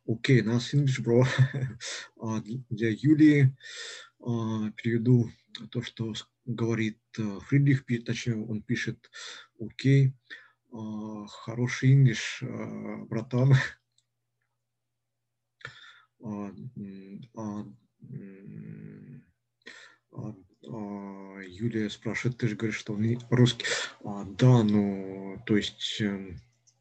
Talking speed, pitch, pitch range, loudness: 90 wpm, 115 Hz, 105-125 Hz, -28 LUFS